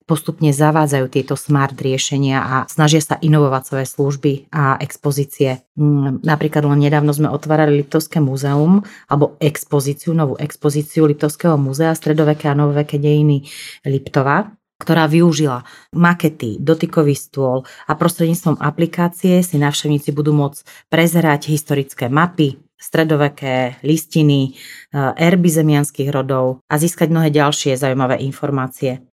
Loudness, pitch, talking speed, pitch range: -16 LUFS, 150 Hz, 115 wpm, 140-160 Hz